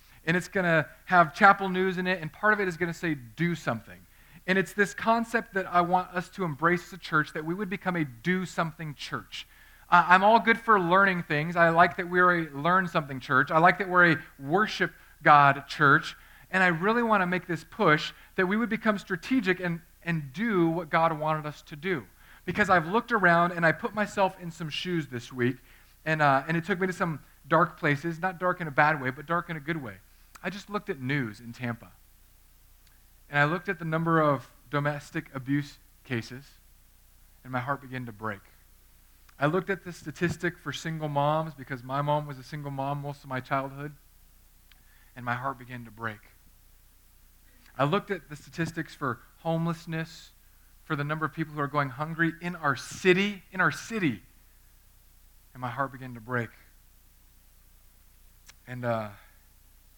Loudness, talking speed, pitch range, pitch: -27 LUFS, 200 wpm, 125-180 Hz, 155 Hz